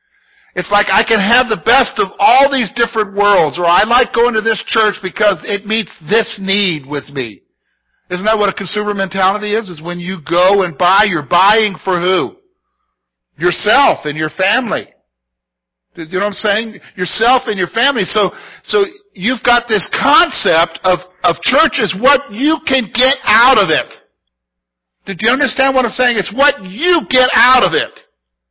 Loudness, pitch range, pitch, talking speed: -12 LUFS, 180-255 Hz, 210 Hz, 180 wpm